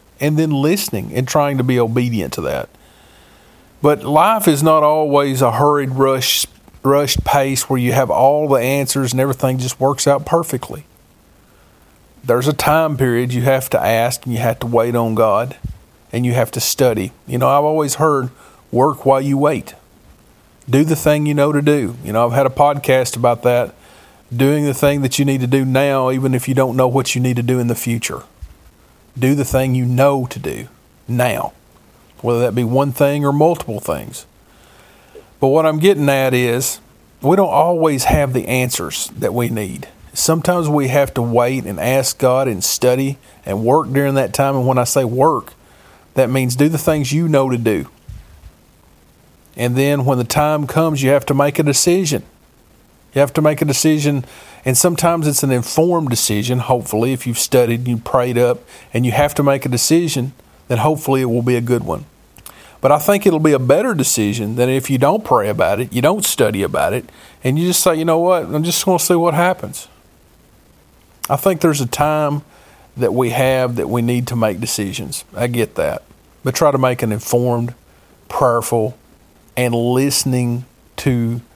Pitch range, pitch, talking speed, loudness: 120-145 Hz, 130 Hz, 195 wpm, -16 LUFS